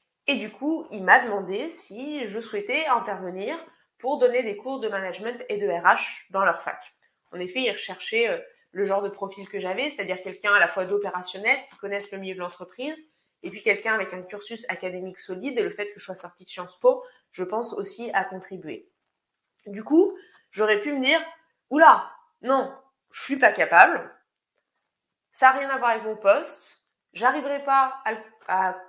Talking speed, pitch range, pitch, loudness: 190 wpm, 195-280 Hz, 220 Hz, -24 LUFS